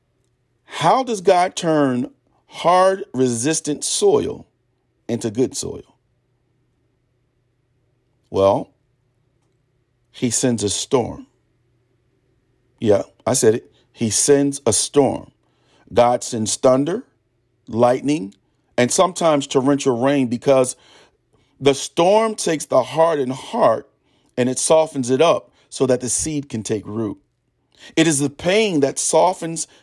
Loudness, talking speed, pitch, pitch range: -18 LUFS, 115 wpm, 125 Hz, 120-145 Hz